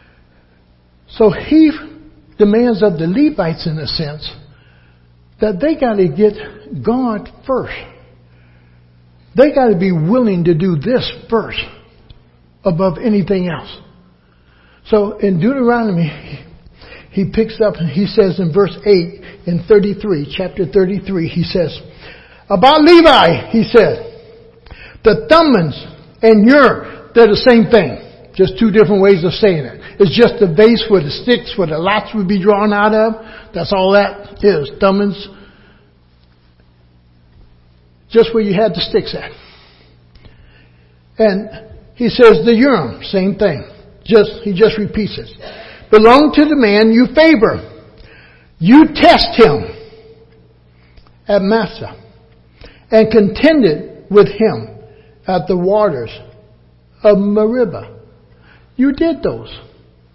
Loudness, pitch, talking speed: -12 LUFS, 195 Hz, 125 wpm